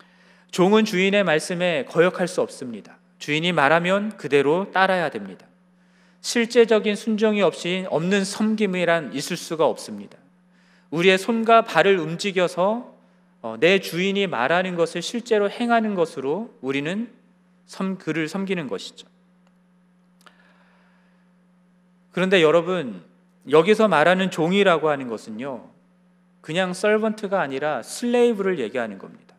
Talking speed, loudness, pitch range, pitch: 280 characters per minute, -21 LUFS, 180-205 Hz, 185 Hz